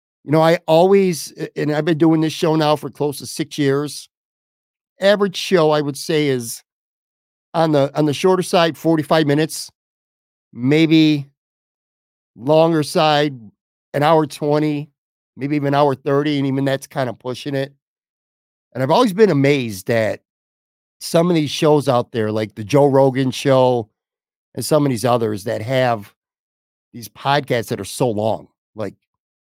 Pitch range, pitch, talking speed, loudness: 120-155 Hz, 140 Hz, 160 wpm, -17 LUFS